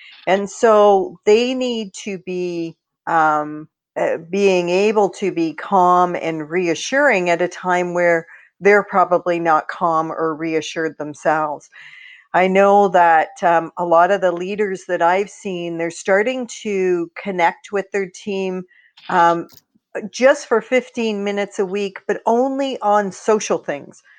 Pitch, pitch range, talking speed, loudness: 185 Hz, 170-205 Hz, 140 wpm, -18 LUFS